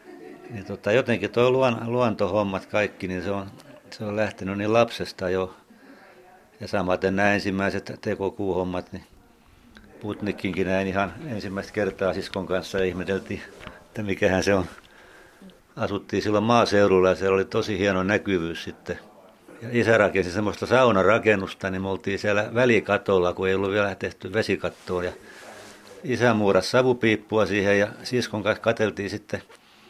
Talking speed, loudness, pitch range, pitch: 135 wpm, -24 LUFS, 95-110 Hz, 100 Hz